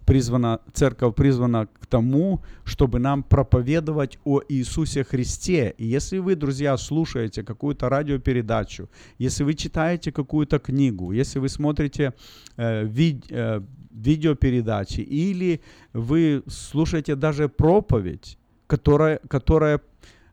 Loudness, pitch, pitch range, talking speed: -23 LUFS, 140 Hz, 120-150 Hz, 110 wpm